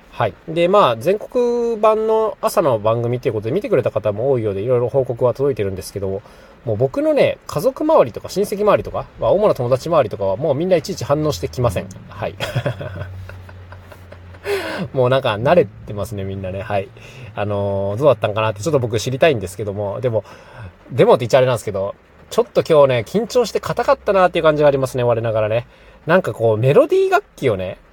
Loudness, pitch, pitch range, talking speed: -18 LUFS, 125 Hz, 100-170 Hz, 440 characters per minute